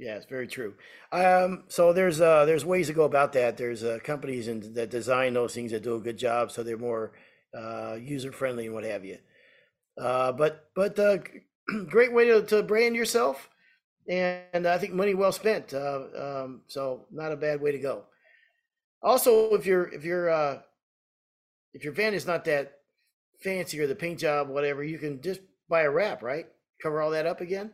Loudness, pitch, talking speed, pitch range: -27 LUFS, 155 Hz, 200 wpm, 130-190 Hz